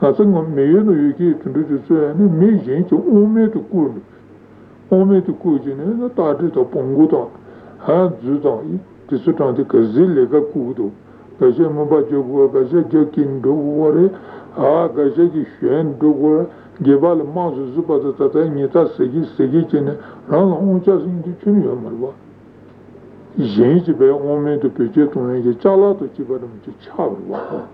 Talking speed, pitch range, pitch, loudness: 145 wpm, 145-190 Hz, 160 Hz, -16 LUFS